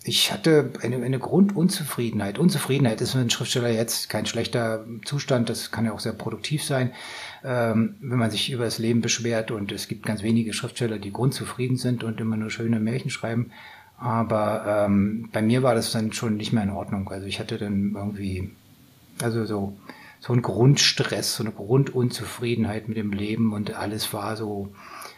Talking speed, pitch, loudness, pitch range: 180 wpm, 115 Hz, -25 LUFS, 105-125 Hz